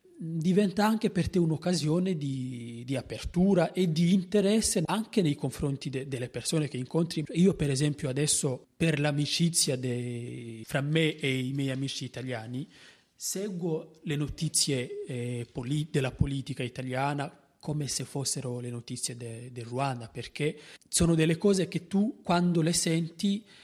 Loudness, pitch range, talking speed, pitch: -29 LUFS, 130-170 Hz, 145 wpm, 150 Hz